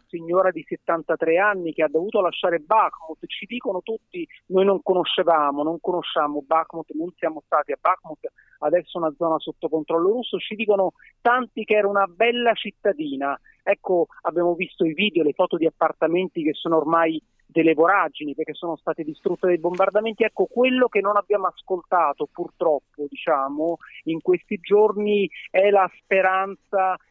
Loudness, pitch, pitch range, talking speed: -22 LUFS, 175 Hz, 160-205 Hz, 155 wpm